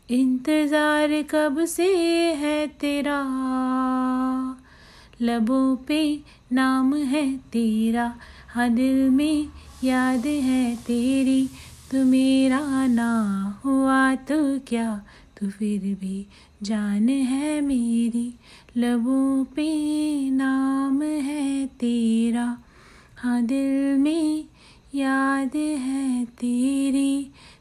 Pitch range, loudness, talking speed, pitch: 240-285 Hz, -23 LUFS, 90 wpm, 265 Hz